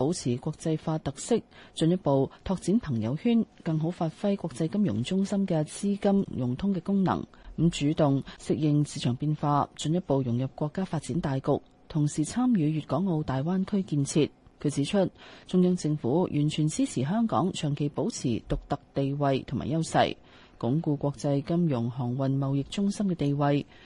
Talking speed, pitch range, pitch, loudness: 265 characters per minute, 140-180 Hz, 155 Hz, -28 LUFS